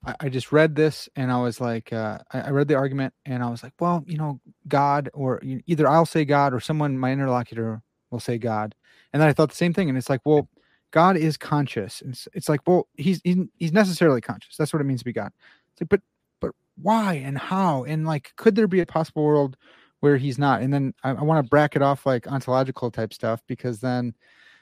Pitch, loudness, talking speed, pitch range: 140 Hz, -23 LUFS, 230 wpm, 125-160 Hz